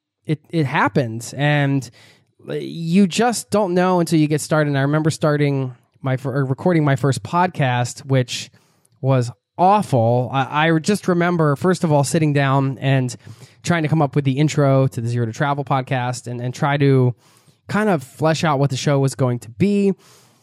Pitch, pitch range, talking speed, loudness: 140 Hz, 130-160 Hz, 185 wpm, -19 LUFS